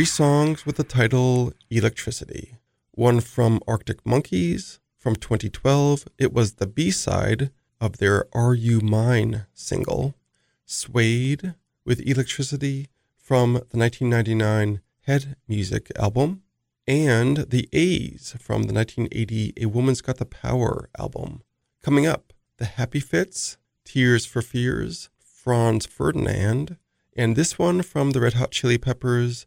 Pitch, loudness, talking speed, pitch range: 120 Hz, -23 LUFS, 130 wpm, 115-135 Hz